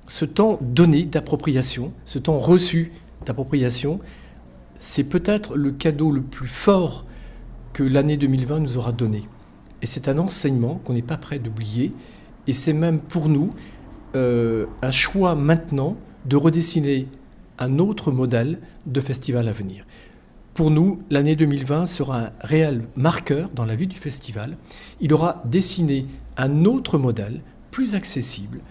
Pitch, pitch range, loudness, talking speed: 145 Hz, 125-165 Hz, -21 LUFS, 145 wpm